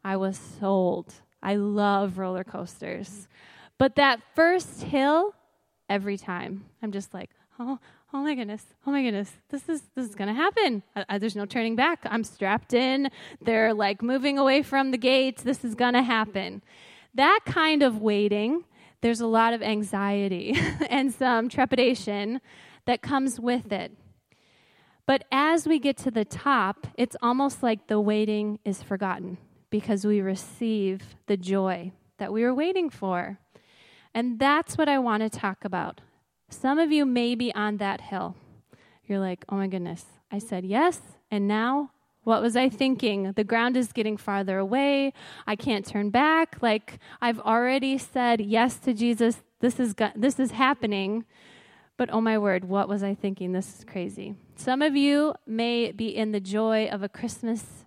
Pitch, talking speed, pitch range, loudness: 225 Hz, 170 wpm, 200-265 Hz, -26 LUFS